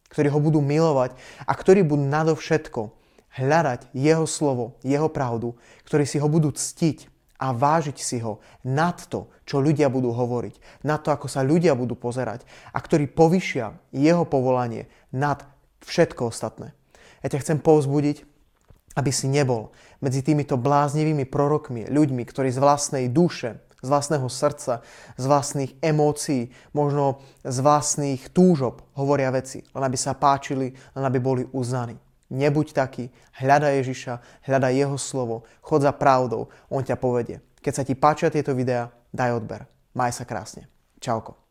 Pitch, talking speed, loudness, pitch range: 140 Hz, 150 wpm, -23 LUFS, 125-150 Hz